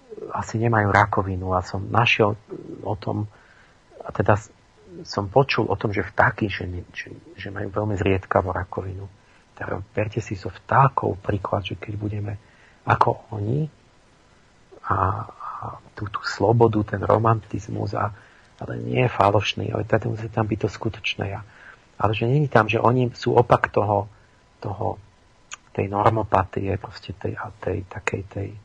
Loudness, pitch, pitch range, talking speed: -23 LUFS, 105 Hz, 100-115 Hz, 150 wpm